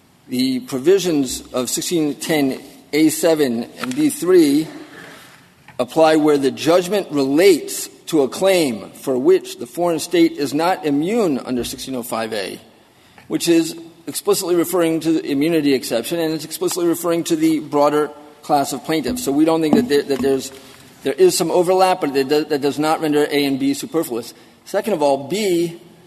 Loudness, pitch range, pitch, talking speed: -18 LUFS, 140-175 Hz, 160 Hz, 150 wpm